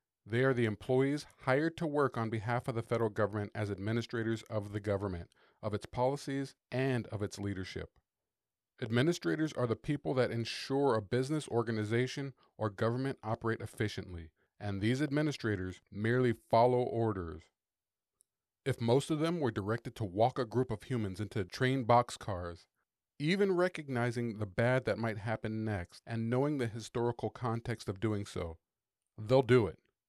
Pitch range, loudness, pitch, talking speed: 105-130 Hz, -34 LUFS, 115 Hz, 155 wpm